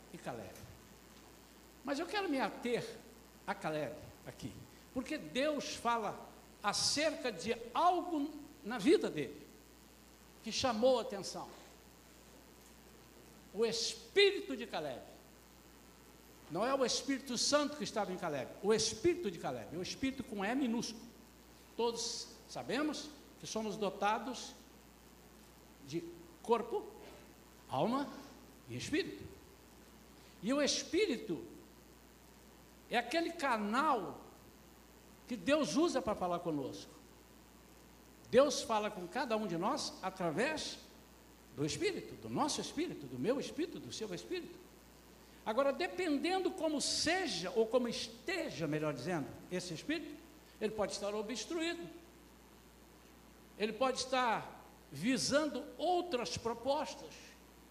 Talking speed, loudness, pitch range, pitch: 115 wpm, -37 LUFS, 210-295 Hz, 250 Hz